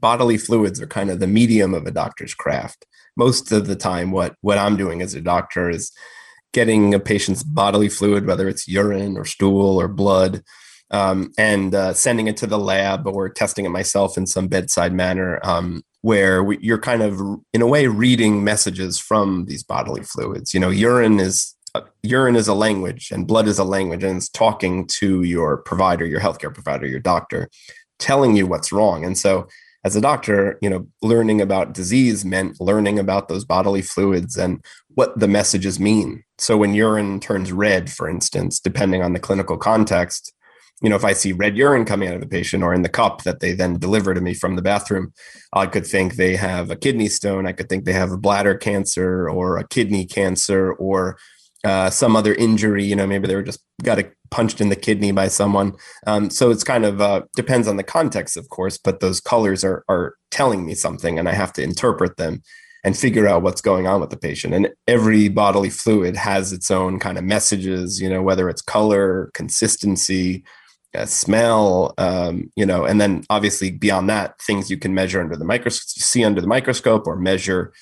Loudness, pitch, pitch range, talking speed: -18 LUFS, 100 Hz, 95-105 Hz, 205 wpm